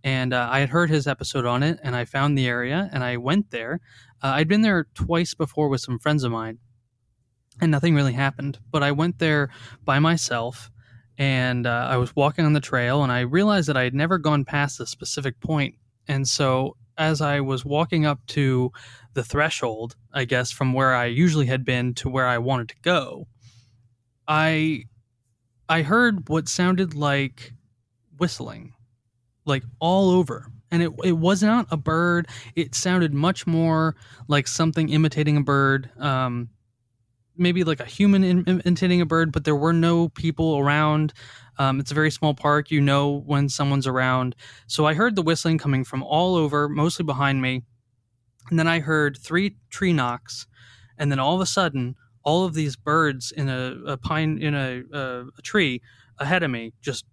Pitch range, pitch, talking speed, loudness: 125-160 Hz, 140 Hz, 185 wpm, -22 LUFS